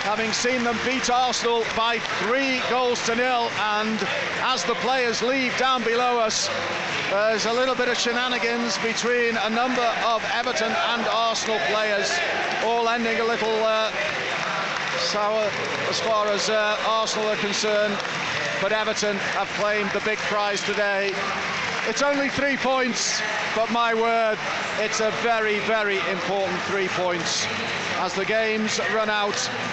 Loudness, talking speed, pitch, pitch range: -23 LUFS, 145 wpm, 220 Hz, 210-235 Hz